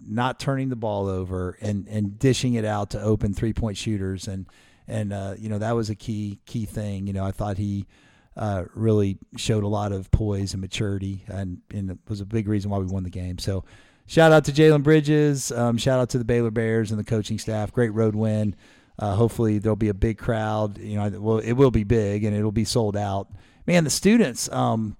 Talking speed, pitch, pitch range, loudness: 230 wpm, 110 Hz, 100-115 Hz, -24 LUFS